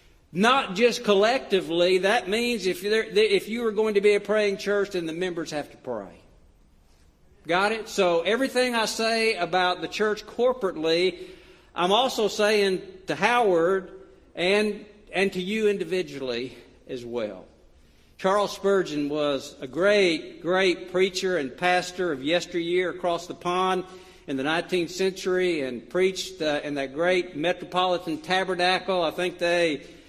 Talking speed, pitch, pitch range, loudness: 145 wpm, 185 Hz, 165-205 Hz, -25 LUFS